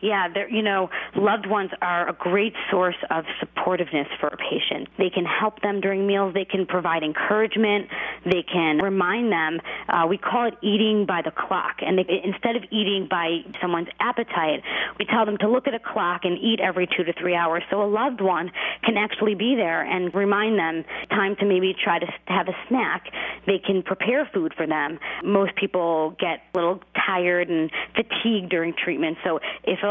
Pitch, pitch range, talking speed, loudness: 195 Hz, 175-210 Hz, 195 wpm, -23 LUFS